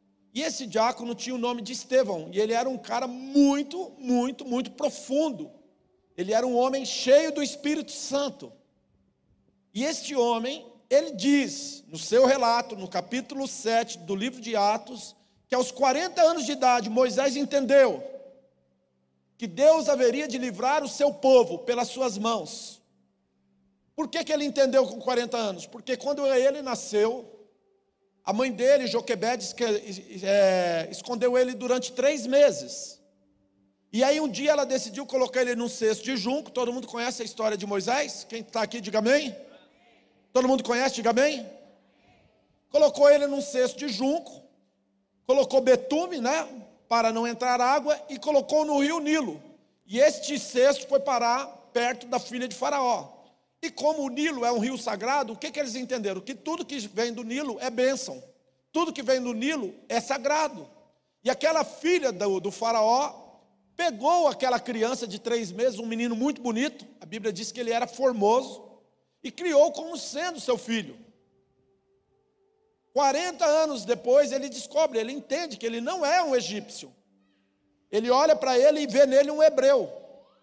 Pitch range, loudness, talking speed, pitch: 230-285 Hz, -26 LUFS, 160 wpm, 255 Hz